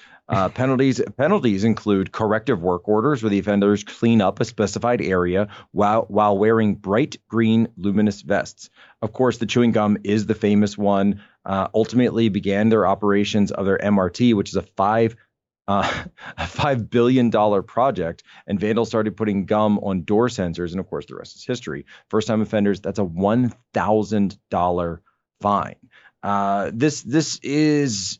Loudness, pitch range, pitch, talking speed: -20 LUFS, 100-115 Hz, 105 Hz, 160 wpm